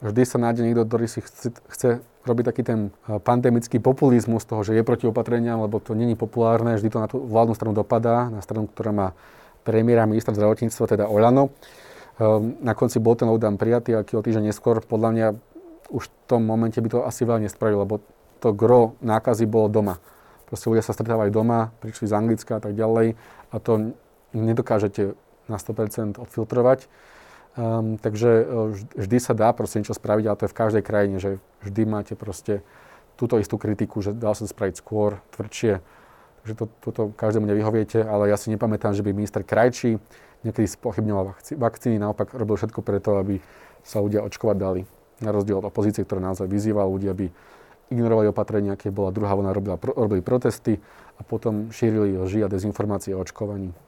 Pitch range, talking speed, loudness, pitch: 105-115 Hz, 180 wpm, -23 LUFS, 110 Hz